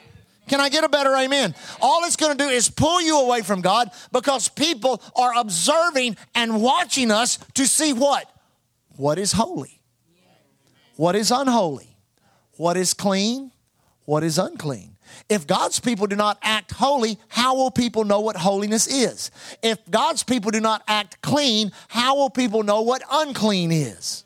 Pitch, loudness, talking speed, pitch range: 230 Hz, -20 LUFS, 165 wpm, 205-270 Hz